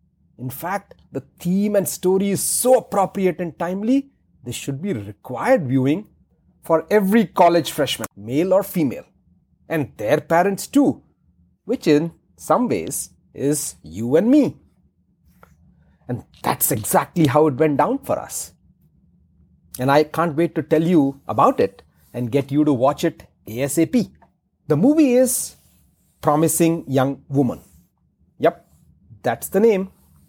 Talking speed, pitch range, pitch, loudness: 140 wpm, 135-195 Hz, 160 Hz, -20 LUFS